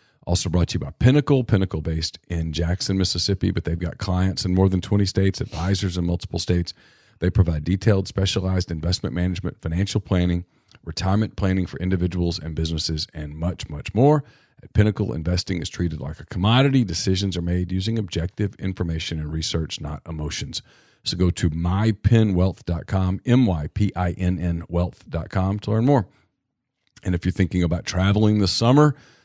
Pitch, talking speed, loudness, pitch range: 90 Hz, 155 wpm, -23 LUFS, 85-100 Hz